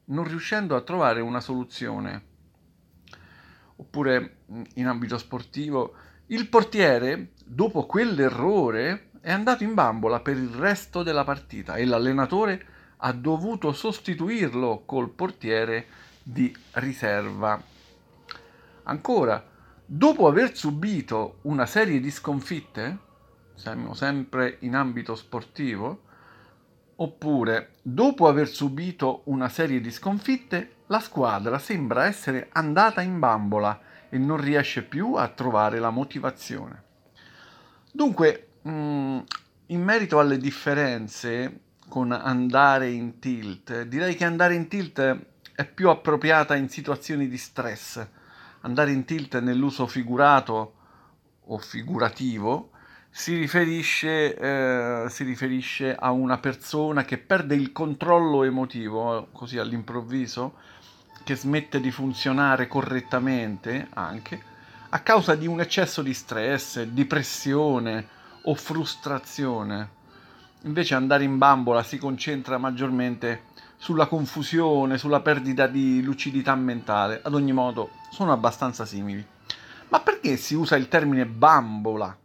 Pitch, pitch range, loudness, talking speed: 135 Hz, 120-155 Hz, -25 LUFS, 115 wpm